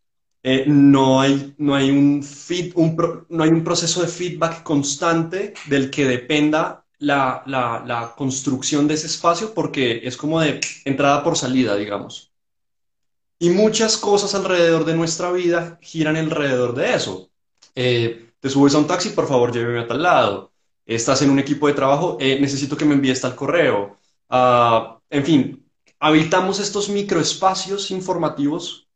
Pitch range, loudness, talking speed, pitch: 130-170 Hz, -19 LUFS, 160 wpm, 145 Hz